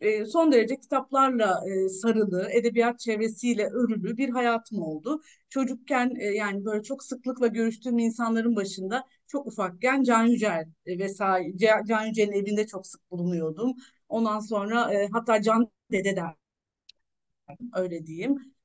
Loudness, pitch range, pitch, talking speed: -26 LUFS, 200-250 Hz, 225 Hz, 115 wpm